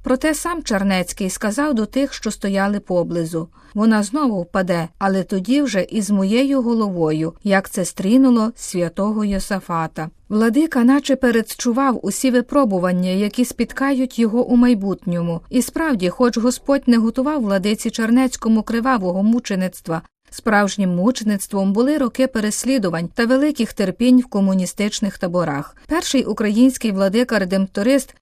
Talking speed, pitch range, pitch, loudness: 120 wpm, 195-255 Hz, 215 Hz, -18 LUFS